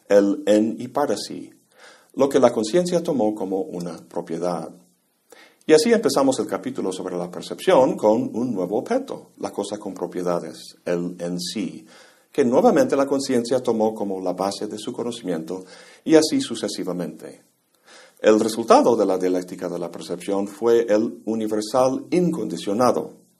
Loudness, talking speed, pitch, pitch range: -22 LUFS, 150 wpm, 100 Hz, 90-115 Hz